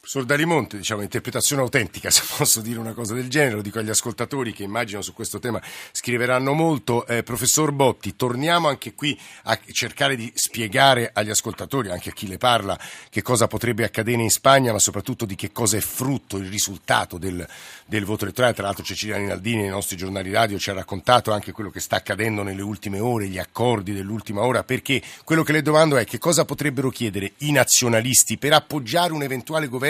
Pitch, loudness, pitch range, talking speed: 115 Hz, -21 LUFS, 105-130 Hz, 195 wpm